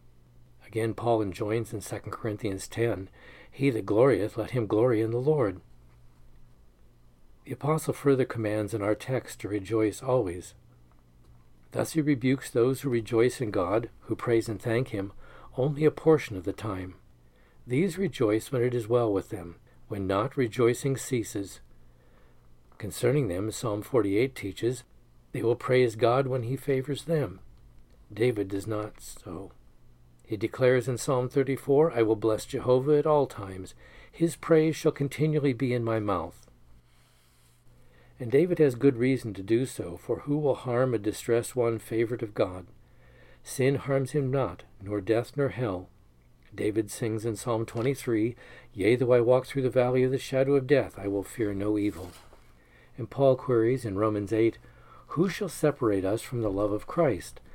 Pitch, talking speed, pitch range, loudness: 115 Hz, 165 wpm, 95-130 Hz, -28 LUFS